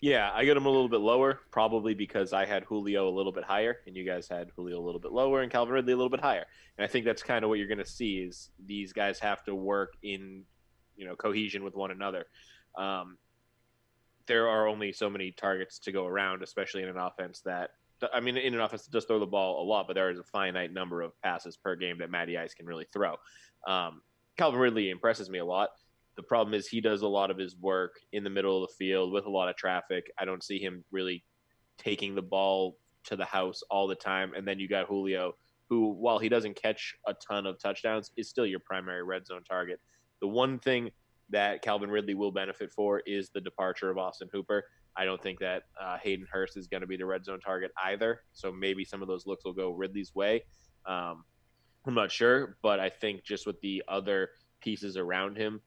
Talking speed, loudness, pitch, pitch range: 235 wpm, -32 LUFS, 95 Hz, 95-105 Hz